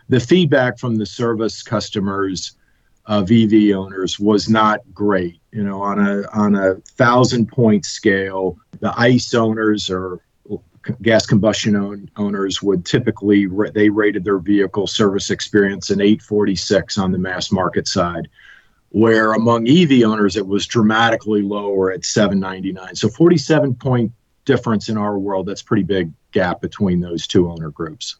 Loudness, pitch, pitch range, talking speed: -17 LUFS, 105 Hz, 100-110 Hz, 145 wpm